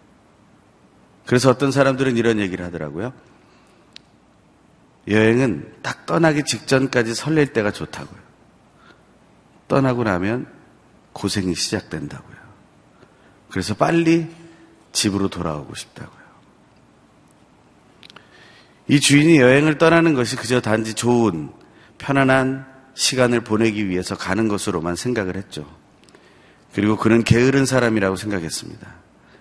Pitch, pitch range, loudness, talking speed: 115 Hz, 100-135 Hz, -19 LUFS, 260 characters per minute